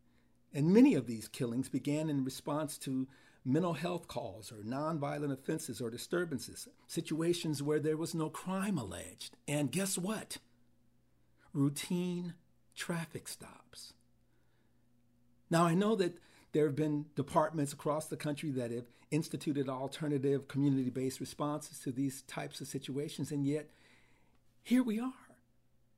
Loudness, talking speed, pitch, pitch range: -36 LUFS, 135 wpm, 145 Hz, 120-155 Hz